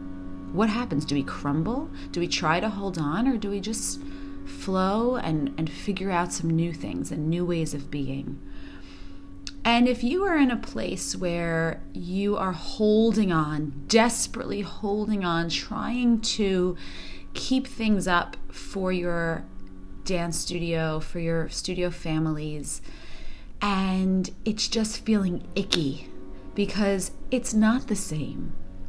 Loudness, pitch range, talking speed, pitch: -26 LUFS, 145-210 Hz, 135 wpm, 175 Hz